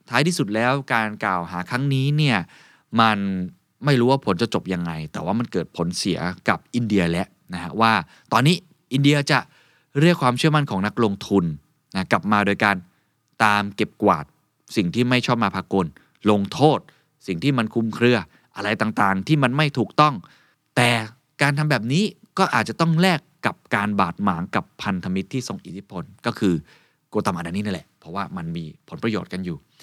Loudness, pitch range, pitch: -22 LUFS, 95-140 Hz, 115 Hz